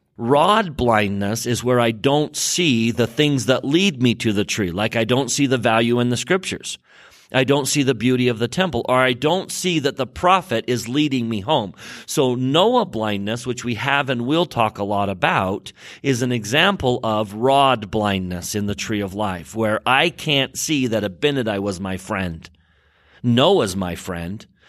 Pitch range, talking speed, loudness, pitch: 105-140 Hz, 190 wpm, -19 LUFS, 120 Hz